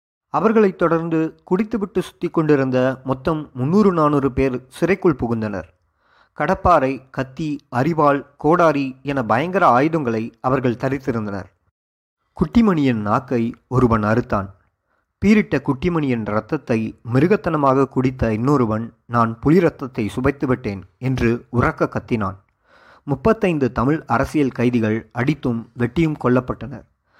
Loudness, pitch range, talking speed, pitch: -19 LUFS, 115-155 Hz, 95 wpm, 130 Hz